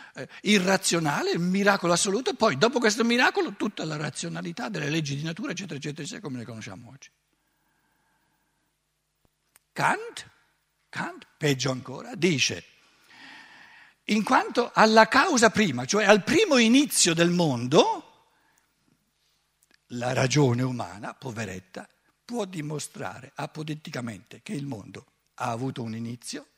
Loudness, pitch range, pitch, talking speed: -24 LUFS, 130-220 Hz, 165 Hz, 115 wpm